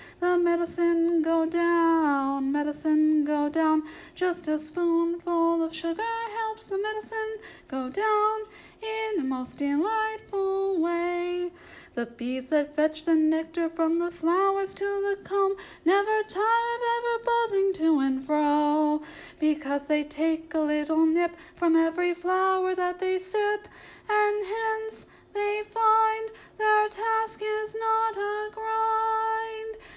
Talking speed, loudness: 130 wpm, -26 LUFS